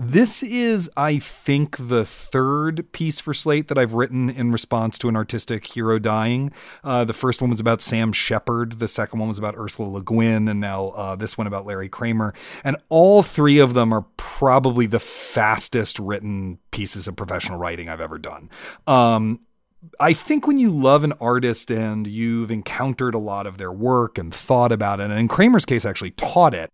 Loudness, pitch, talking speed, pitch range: -20 LUFS, 115 Hz, 195 wpm, 105-135 Hz